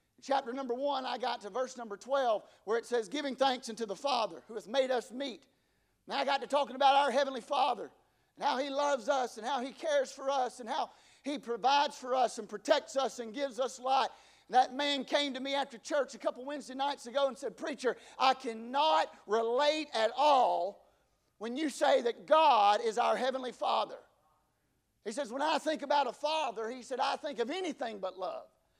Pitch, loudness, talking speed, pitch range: 270 Hz, -32 LUFS, 210 wpm, 240-285 Hz